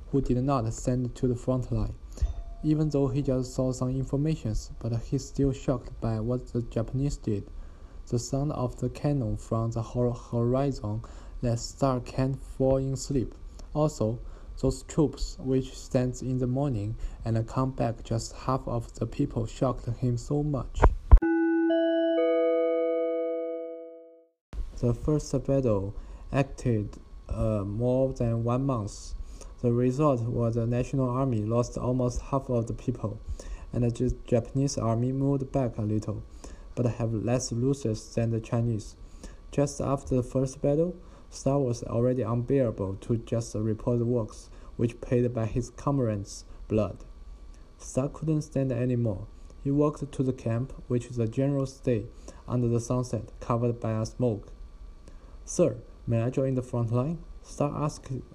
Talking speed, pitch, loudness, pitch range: 150 wpm, 125 Hz, -29 LUFS, 110-135 Hz